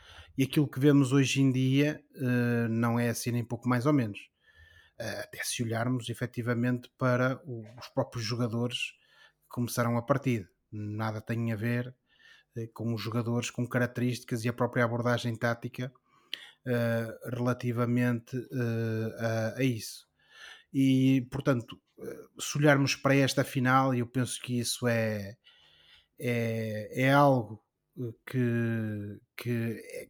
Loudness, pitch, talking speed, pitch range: -30 LUFS, 120 Hz, 125 wpm, 115-130 Hz